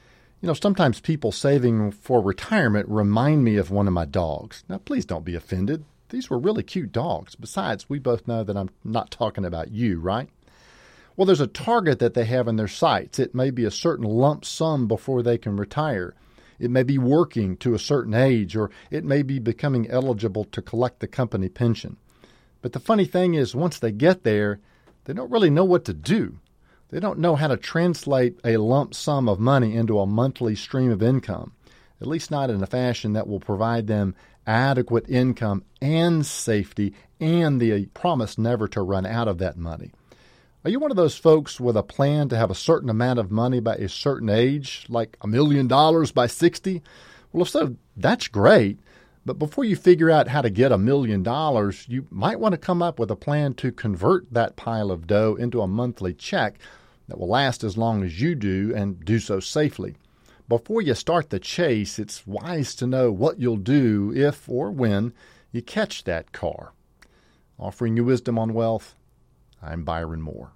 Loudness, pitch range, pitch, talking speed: -23 LUFS, 105-140 Hz, 120 Hz, 195 wpm